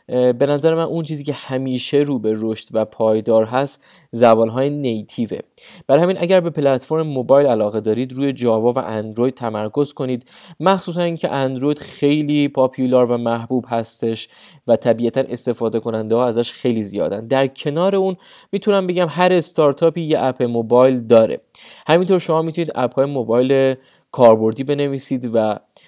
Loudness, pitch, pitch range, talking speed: -18 LUFS, 130 Hz, 115-155 Hz, 155 wpm